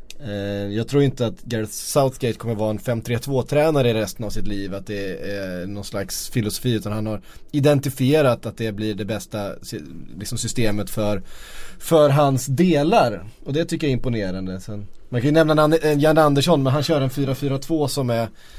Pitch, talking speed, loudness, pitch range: 120 Hz, 180 wpm, -21 LUFS, 105-145 Hz